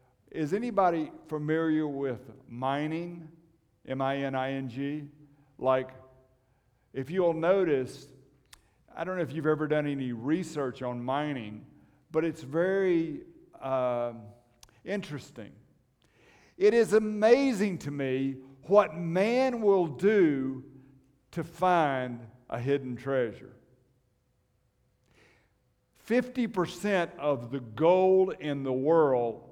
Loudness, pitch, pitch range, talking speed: -29 LUFS, 140 Hz, 130-170 Hz, 105 wpm